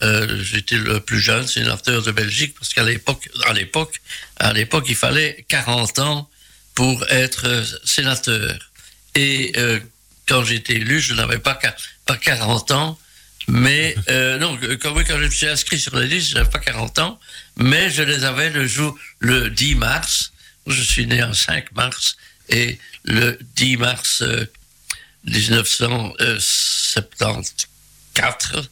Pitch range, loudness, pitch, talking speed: 115-145 Hz, -17 LUFS, 125 Hz, 150 wpm